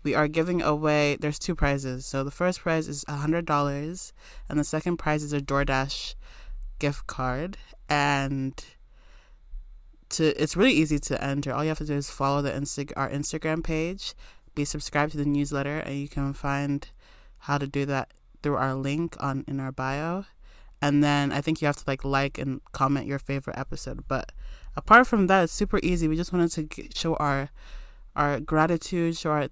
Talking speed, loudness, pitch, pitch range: 190 wpm, -27 LUFS, 145 Hz, 140-155 Hz